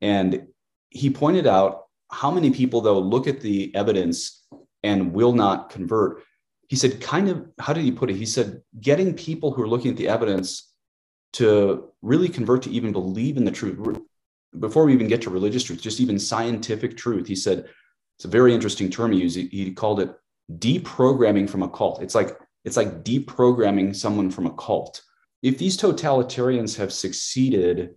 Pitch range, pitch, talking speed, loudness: 100-130 Hz, 115 Hz, 180 wpm, -22 LUFS